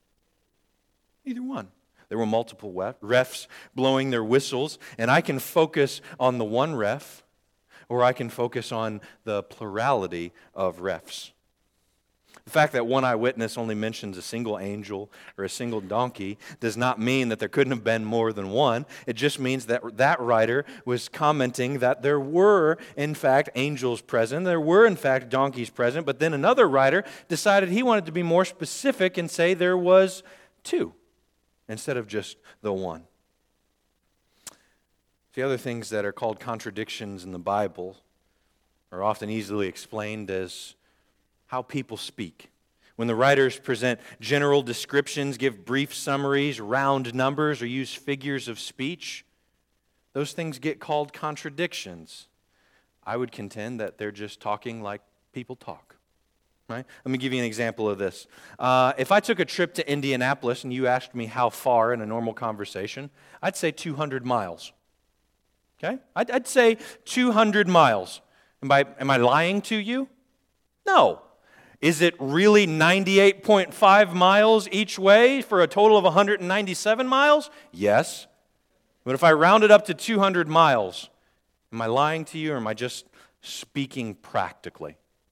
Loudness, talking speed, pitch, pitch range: -23 LUFS, 155 wpm, 135 Hz, 115-170 Hz